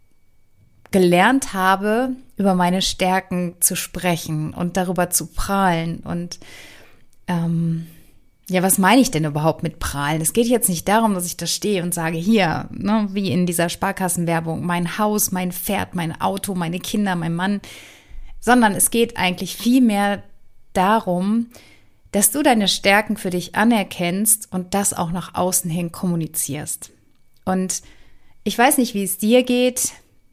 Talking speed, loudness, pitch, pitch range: 150 wpm, -19 LUFS, 185 Hz, 170-205 Hz